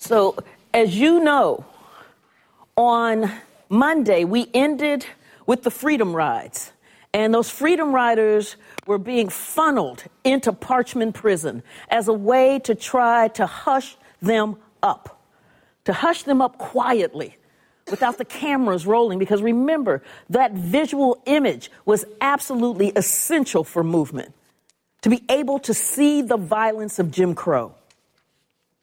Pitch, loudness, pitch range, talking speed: 235 Hz, -20 LUFS, 210-270 Hz, 125 wpm